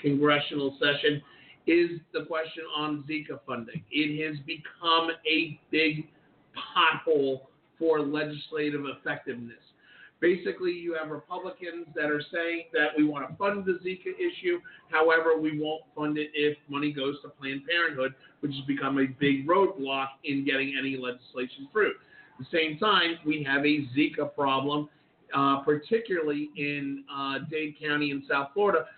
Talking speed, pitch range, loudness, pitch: 150 wpm, 140-165 Hz, -28 LUFS, 150 Hz